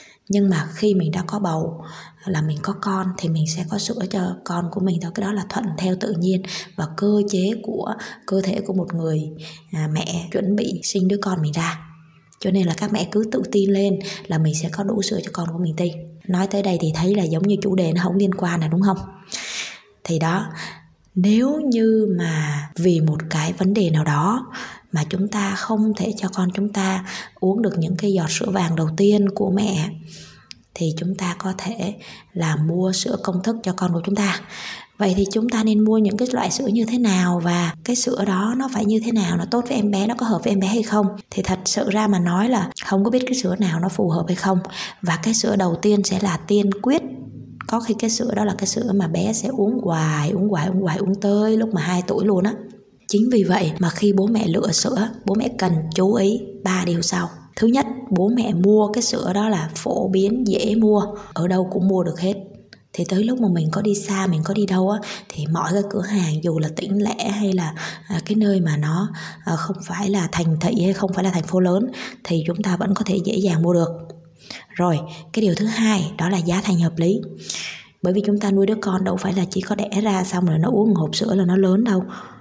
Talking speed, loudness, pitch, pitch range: 245 wpm, -21 LUFS, 195 Hz, 175-210 Hz